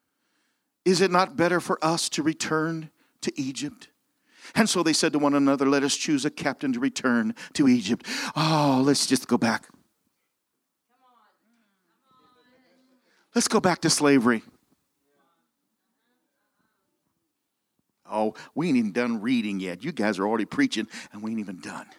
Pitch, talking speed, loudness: 175 Hz, 145 wpm, -24 LUFS